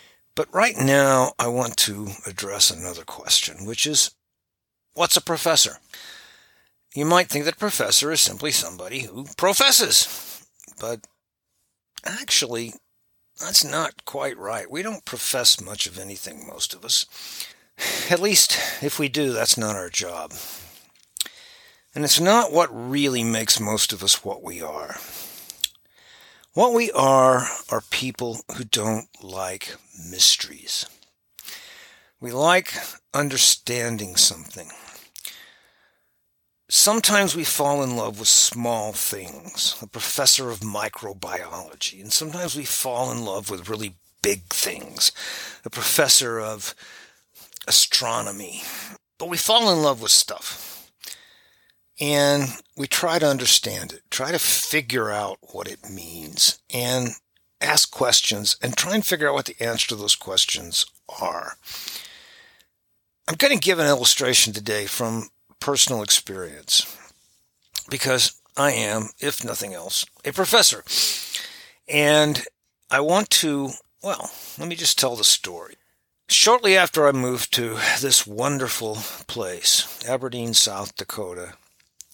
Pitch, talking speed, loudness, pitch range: 130 Hz, 130 wpm, -20 LUFS, 110-155 Hz